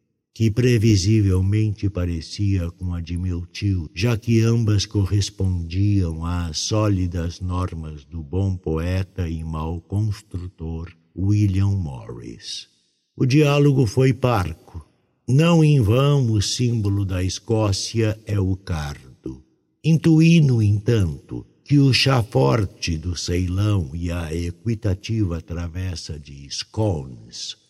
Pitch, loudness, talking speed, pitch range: 95 Hz, -21 LUFS, 115 wpm, 85-115 Hz